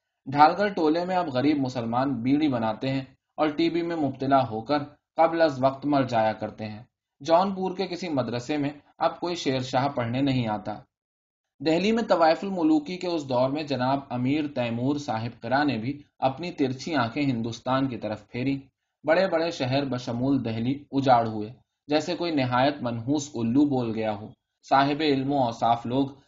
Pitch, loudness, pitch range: 135 Hz, -26 LUFS, 120-155 Hz